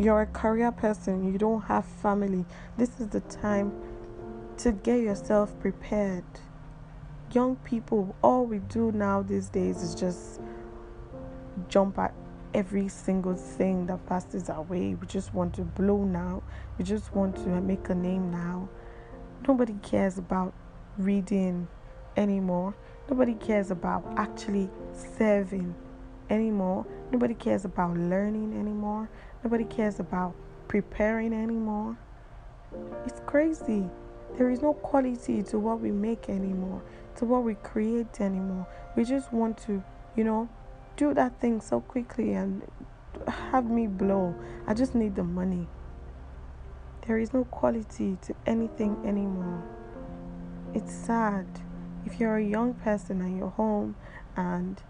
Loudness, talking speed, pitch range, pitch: -29 LUFS, 135 wpm, 170-220 Hz, 195 Hz